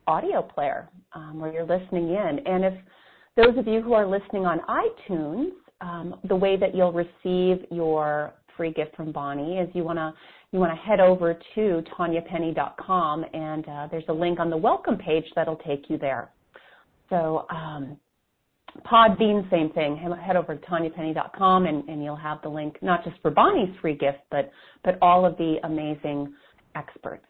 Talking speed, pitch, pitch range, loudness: 175 wpm, 170 Hz, 155-185 Hz, -25 LUFS